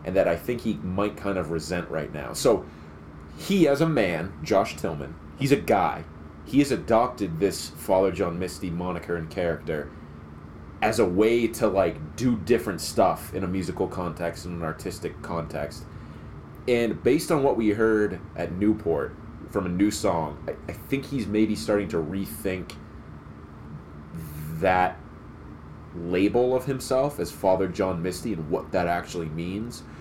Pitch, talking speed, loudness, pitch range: 90 Hz, 160 wpm, -26 LUFS, 80-105 Hz